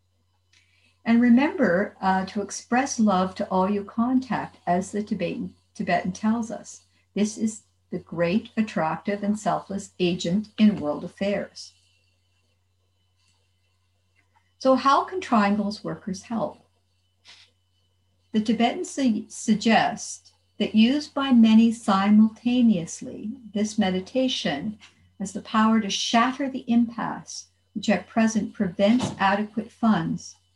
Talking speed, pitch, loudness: 110 wpm, 200 Hz, -24 LUFS